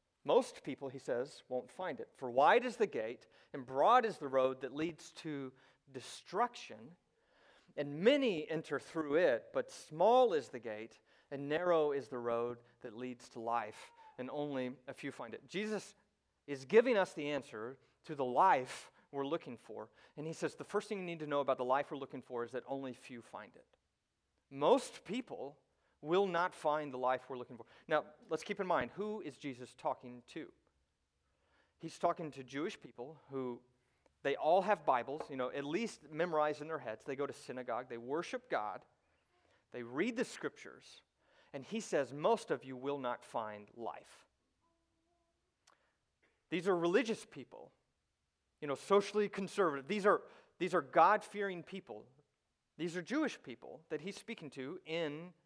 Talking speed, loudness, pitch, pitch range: 175 wpm, -37 LUFS, 150 Hz, 130-190 Hz